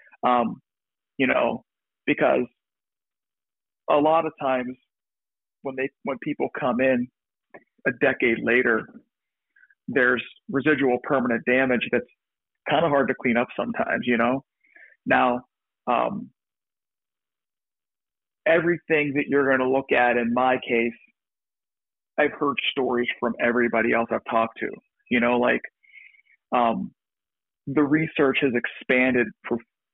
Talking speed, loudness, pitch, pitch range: 120 wpm, -23 LUFS, 130 Hz, 120-145 Hz